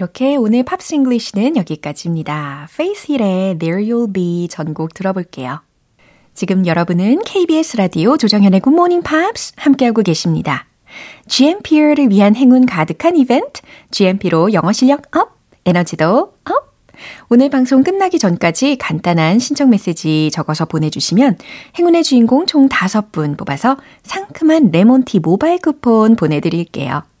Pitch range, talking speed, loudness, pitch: 170-280 Hz, 345 characters per minute, -13 LUFS, 220 Hz